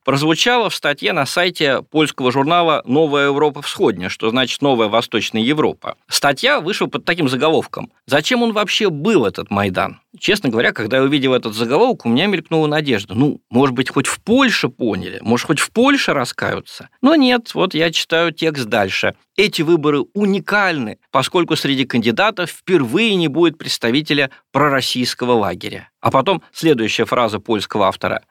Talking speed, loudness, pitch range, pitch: 155 wpm, -16 LUFS, 120-170 Hz, 145 Hz